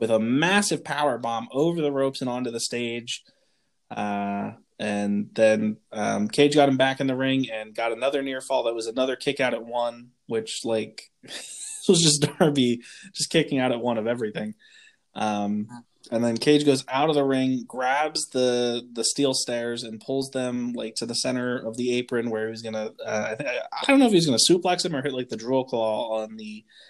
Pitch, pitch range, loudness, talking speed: 125 Hz, 115-140 Hz, -24 LUFS, 210 wpm